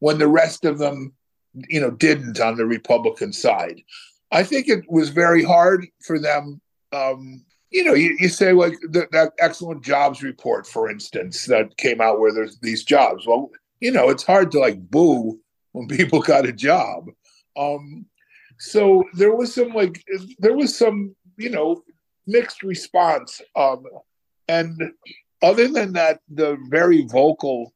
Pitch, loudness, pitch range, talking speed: 165 Hz, -19 LUFS, 140-200 Hz, 160 wpm